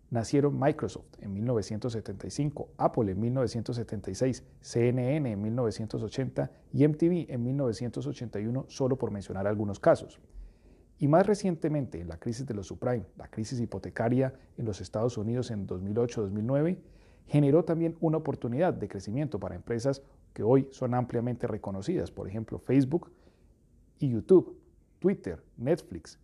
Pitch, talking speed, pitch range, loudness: 120 Hz, 130 wpm, 105-140 Hz, -30 LUFS